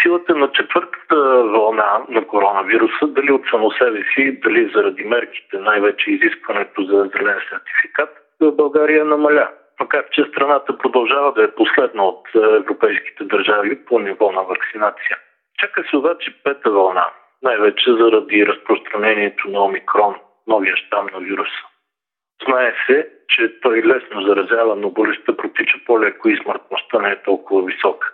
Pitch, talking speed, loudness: 345 Hz, 140 wpm, -16 LUFS